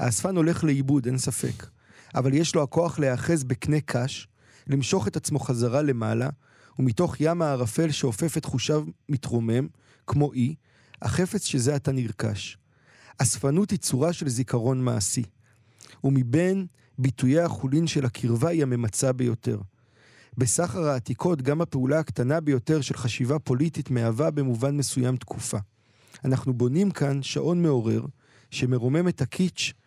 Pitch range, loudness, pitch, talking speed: 120-150 Hz, -25 LUFS, 135 Hz, 130 wpm